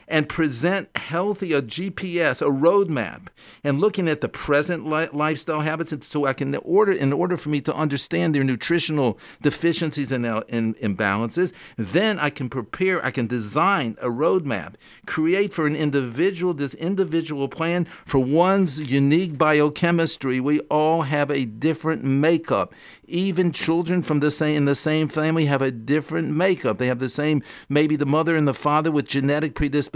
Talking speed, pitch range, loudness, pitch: 165 wpm, 140-170 Hz, -22 LUFS, 150 Hz